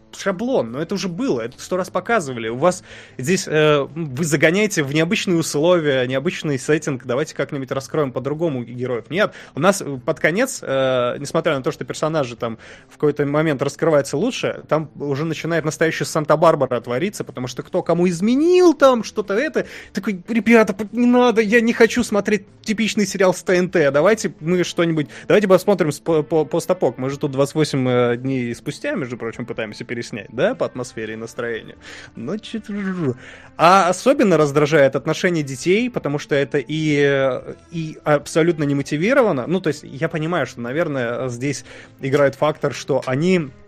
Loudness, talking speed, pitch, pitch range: -19 LUFS, 165 wpm, 155 Hz, 135-185 Hz